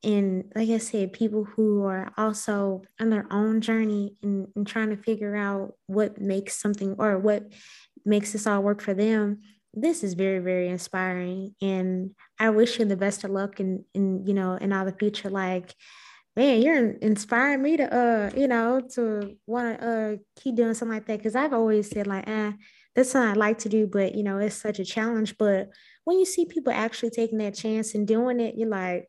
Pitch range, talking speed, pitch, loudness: 200-225 Hz, 210 wpm, 210 Hz, -26 LUFS